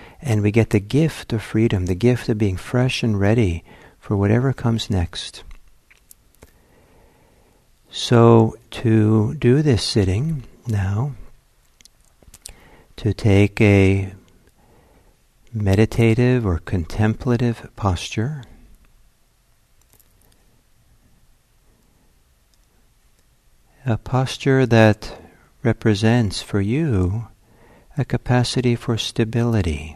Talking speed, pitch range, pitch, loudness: 80 wpm, 100-120 Hz, 110 Hz, -19 LUFS